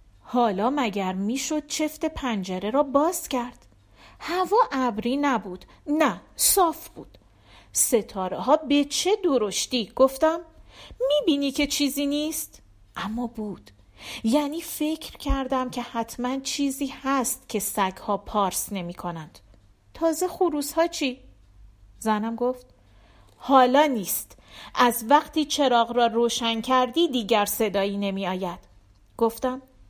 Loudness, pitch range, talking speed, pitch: -24 LUFS, 200-290 Hz, 115 wpm, 245 Hz